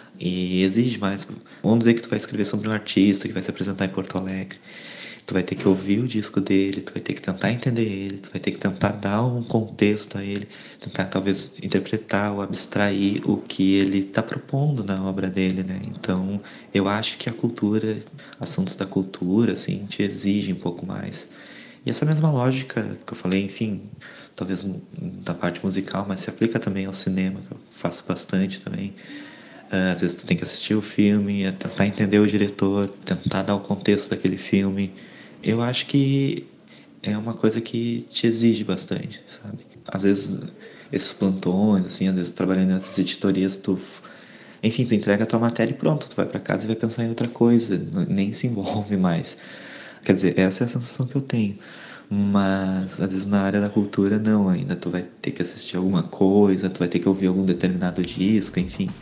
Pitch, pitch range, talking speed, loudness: 100 Hz, 95-110 Hz, 195 wpm, -23 LUFS